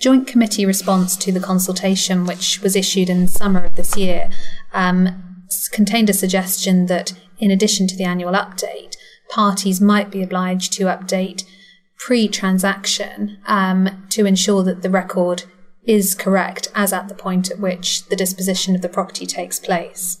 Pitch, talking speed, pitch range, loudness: 190 Hz, 160 wpm, 185-200 Hz, -18 LUFS